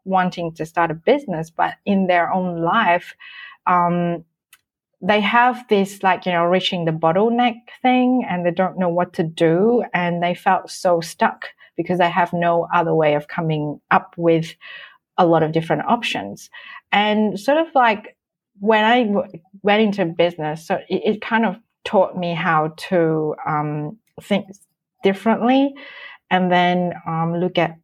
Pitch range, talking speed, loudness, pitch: 170-215 Hz, 160 wpm, -19 LUFS, 180 Hz